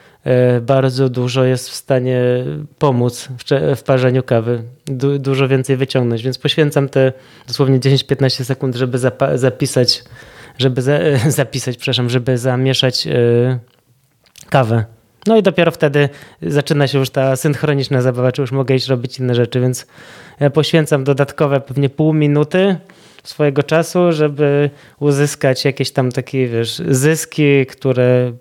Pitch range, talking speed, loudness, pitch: 125-145 Hz, 135 wpm, -15 LUFS, 135 Hz